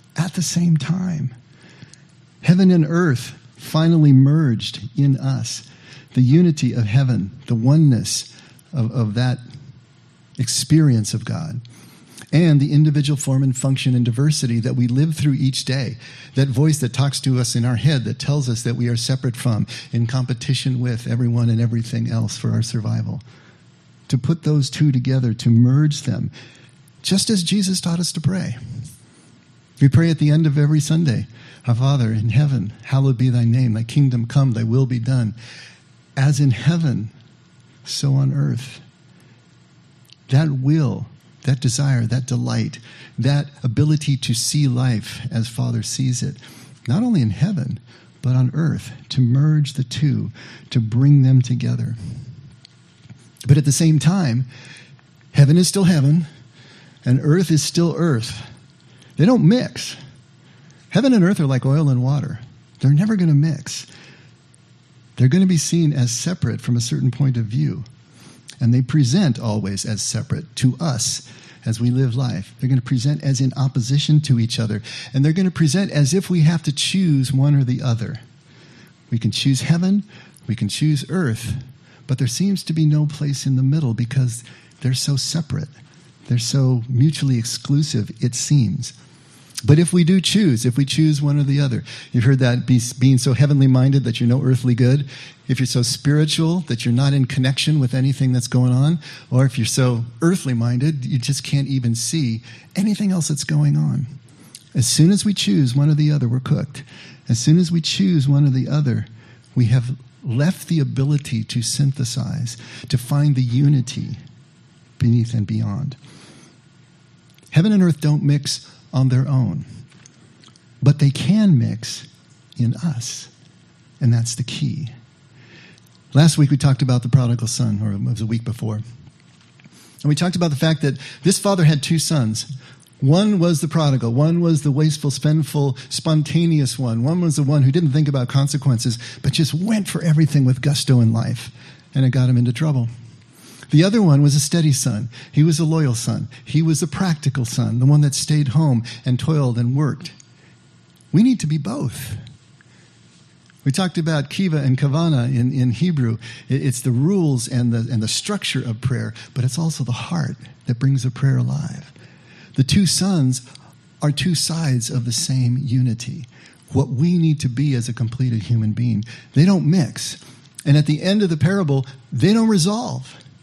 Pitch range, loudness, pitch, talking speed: 125-150 Hz, -18 LUFS, 135 Hz, 175 wpm